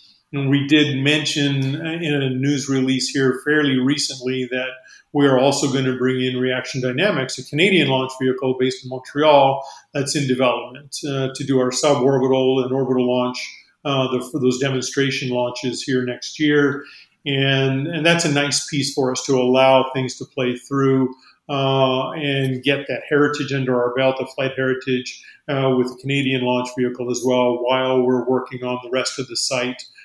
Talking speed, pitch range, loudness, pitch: 180 wpm, 130-140 Hz, -19 LUFS, 130 Hz